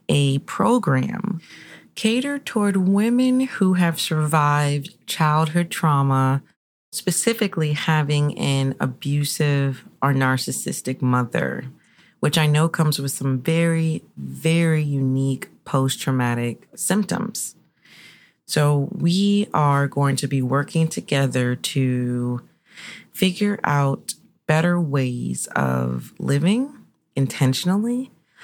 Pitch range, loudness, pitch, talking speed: 135-180 Hz, -21 LUFS, 150 Hz, 95 wpm